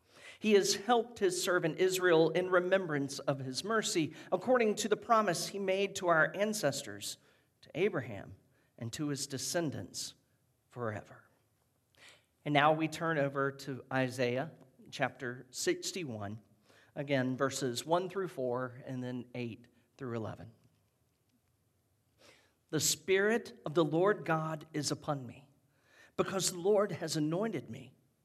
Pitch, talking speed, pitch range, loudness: 140 Hz, 130 wpm, 125-180 Hz, -33 LUFS